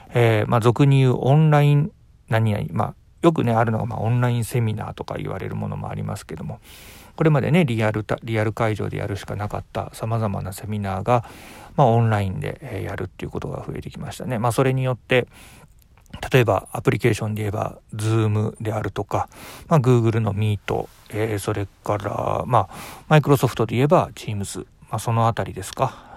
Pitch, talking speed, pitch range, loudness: 115 Hz, 430 characters per minute, 105-125 Hz, -22 LUFS